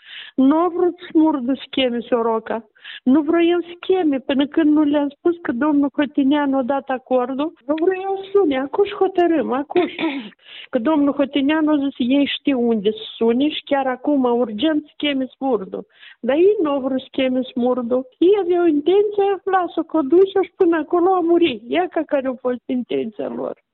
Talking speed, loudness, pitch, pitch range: 170 wpm, -19 LUFS, 295 Hz, 265-345 Hz